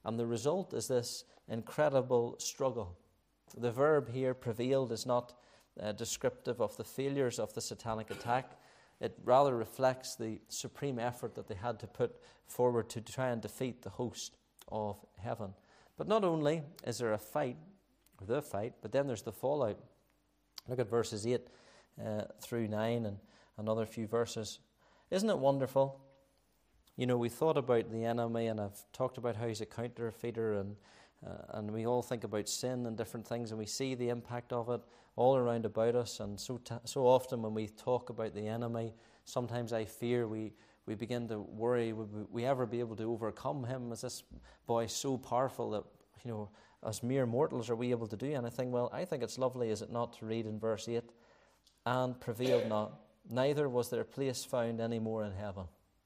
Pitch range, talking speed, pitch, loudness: 110-125 Hz, 190 wpm, 120 Hz, -37 LUFS